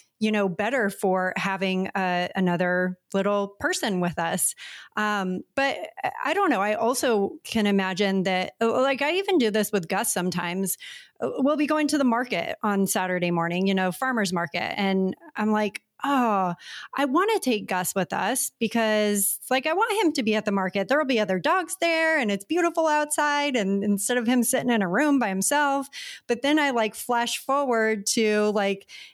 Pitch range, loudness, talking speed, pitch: 195-275 Hz, -24 LUFS, 190 wpm, 215 Hz